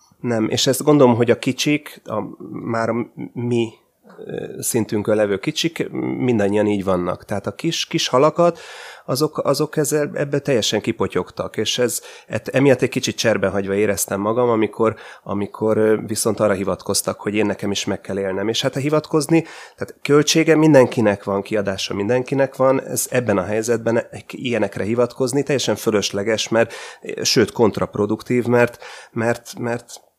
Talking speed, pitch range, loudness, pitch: 145 wpm, 105-135 Hz, -19 LUFS, 115 Hz